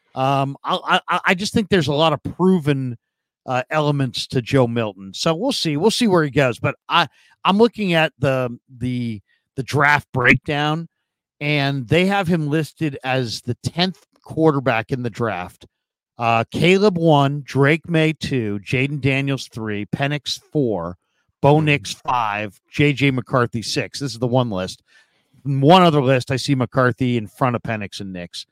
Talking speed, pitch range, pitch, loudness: 170 wpm, 125-155 Hz, 140 Hz, -19 LUFS